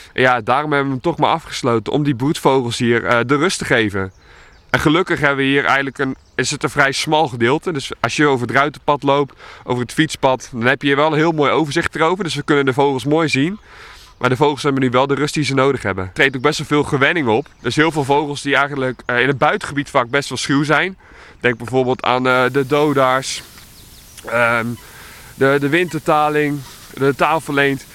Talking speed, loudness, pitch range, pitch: 225 wpm, -17 LUFS, 125-150 Hz, 140 Hz